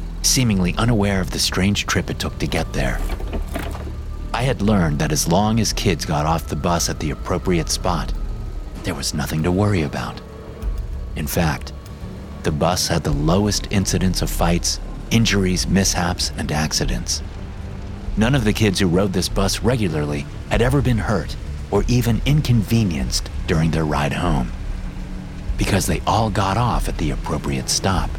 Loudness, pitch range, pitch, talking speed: -20 LUFS, 75-100 Hz, 90 Hz, 160 wpm